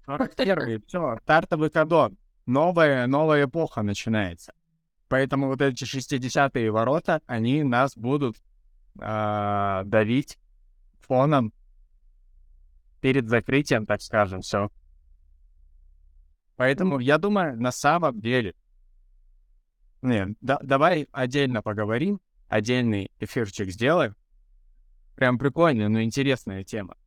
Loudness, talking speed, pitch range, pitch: -24 LUFS, 95 wpm, 95-140 Hz, 115 Hz